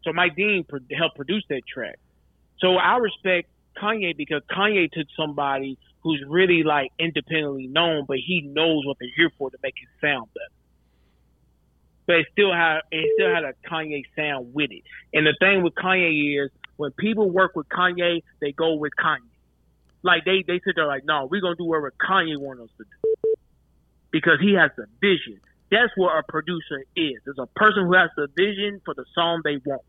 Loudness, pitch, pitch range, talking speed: -22 LUFS, 160 Hz, 140-185 Hz, 200 wpm